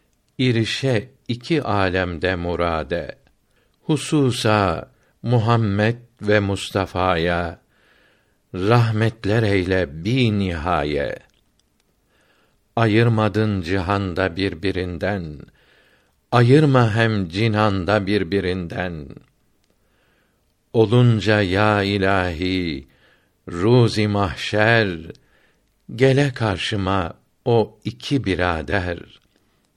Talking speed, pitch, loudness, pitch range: 60 wpm, 105 Hz, -20 LUFS, 95-115 Hz